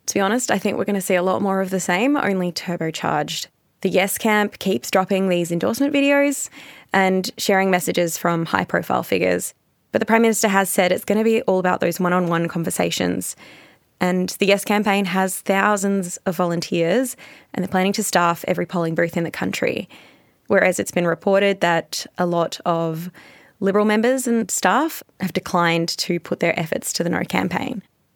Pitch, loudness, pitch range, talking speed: 190 Hz, -20 LUFS, 175-205 Hz, 190 wpm